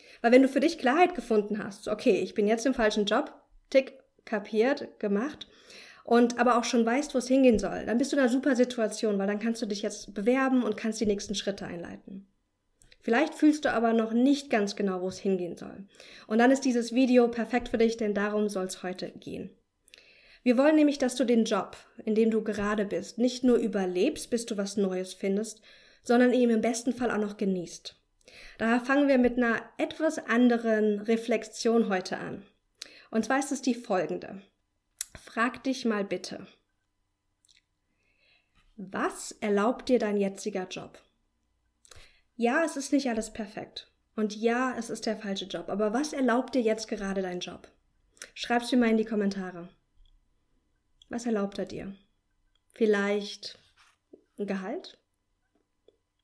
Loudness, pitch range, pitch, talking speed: -28 LUFS, 205-245 Hz, 225 Hz, 170 wpm